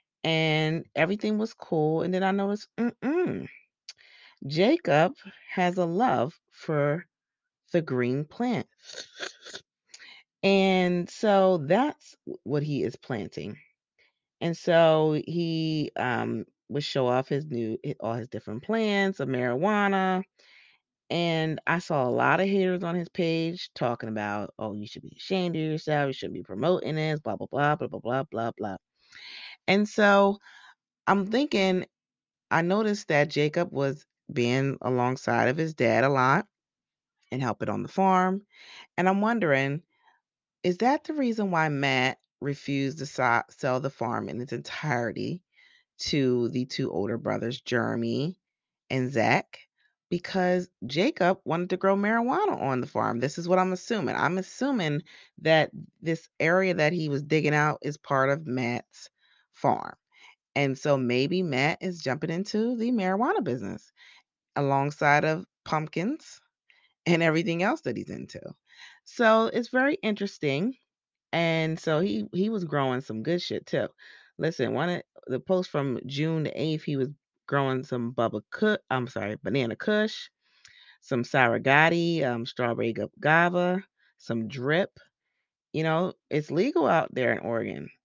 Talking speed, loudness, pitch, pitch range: 145 wpm, -27 LUFS, 160 Hz, 130-190 Hz